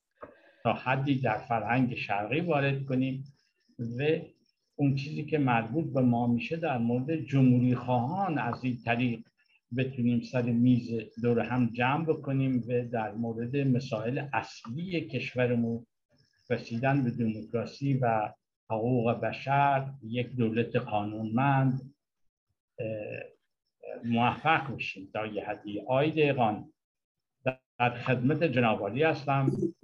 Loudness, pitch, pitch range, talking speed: -30 LUFS, 125 Hz, 115-140 Hz, 110 wpm